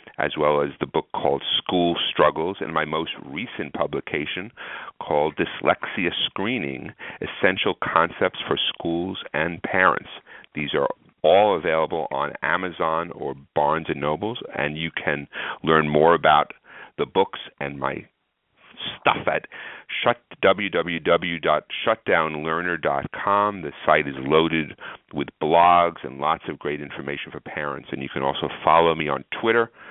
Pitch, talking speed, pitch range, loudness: 80 Hz, 130 wpm, 75-85 Hz, -23 LUFS